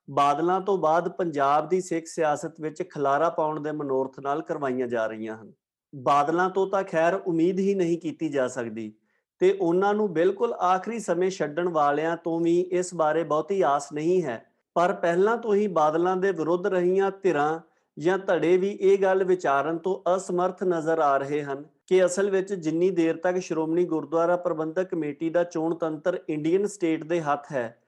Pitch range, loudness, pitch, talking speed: 150-185 Hz, -25 LUFS, 170 Hz, 175 wpm